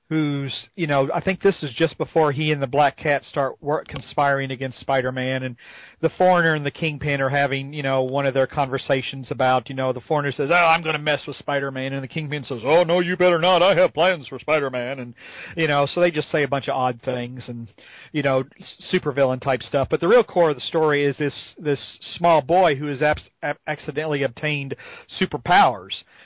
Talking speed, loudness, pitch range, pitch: 230 wpm, -21 LUFS, 135-160 Hz, 145 Hz